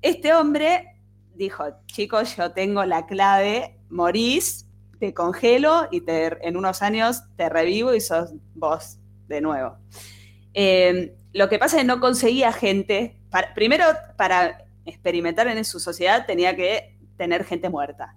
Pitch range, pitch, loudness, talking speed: 150-220 Hz, 180 Hz, -21 LUFS, 145 wpm